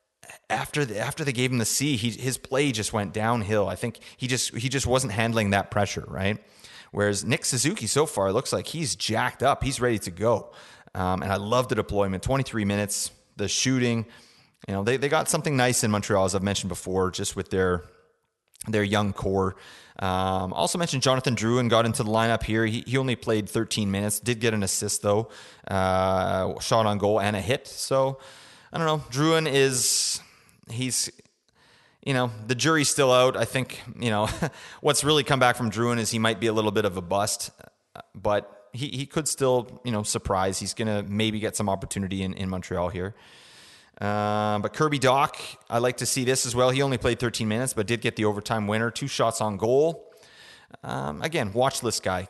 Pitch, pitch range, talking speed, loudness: 115 Hz, 105-130 Hz, 210 wpm, -25 LUFS